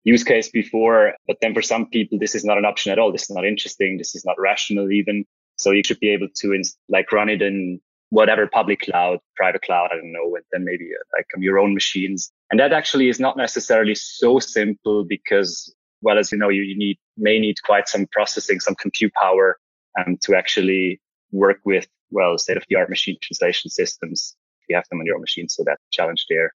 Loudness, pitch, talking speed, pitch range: -19 LUFS, 105 Hz, 230 wpm, 100-120 Hz